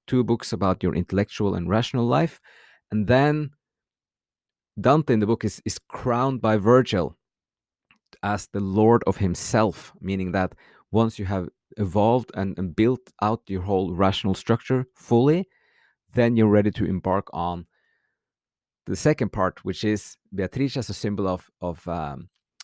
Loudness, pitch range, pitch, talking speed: -24 LUFS, 95-120 Hz, 105 Hz, 150 wpm